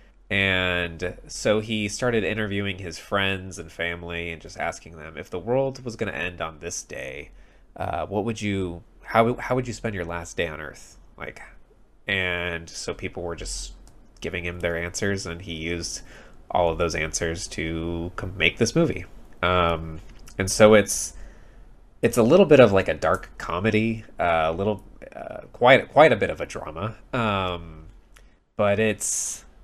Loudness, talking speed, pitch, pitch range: -24 LUFS, 175 wpm, 95 Hz, 85-105 Hz